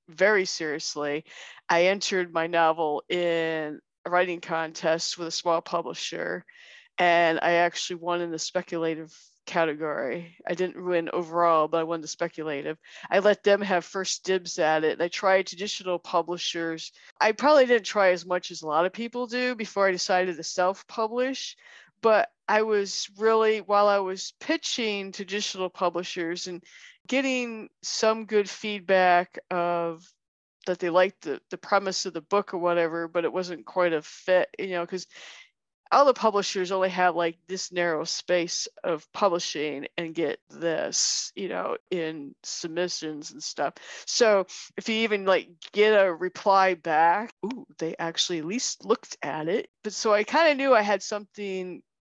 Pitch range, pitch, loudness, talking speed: 170-205 Hz, 180 Hz, -26 LUFS, 165 wpm